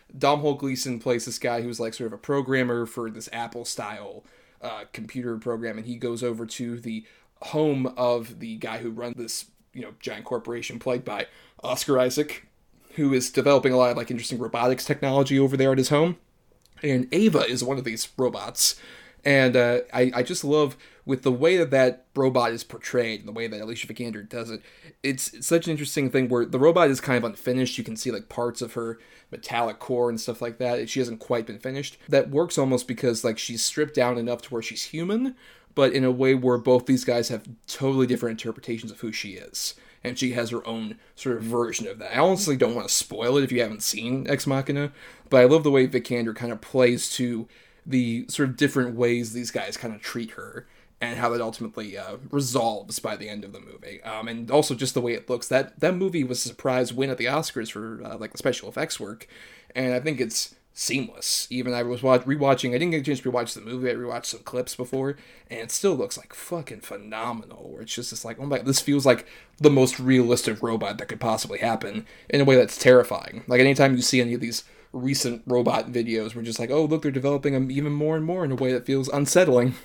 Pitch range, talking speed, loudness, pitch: 115-135 Hz, 230 wpm, -24 LUFS, 125 Hz